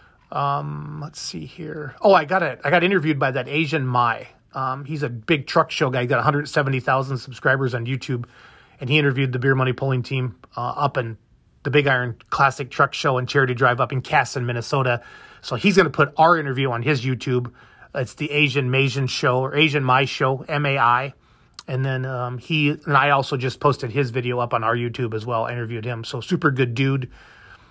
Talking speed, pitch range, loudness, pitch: 210 wpm, 125-150 Hz, -21 LUFS, 135 Hz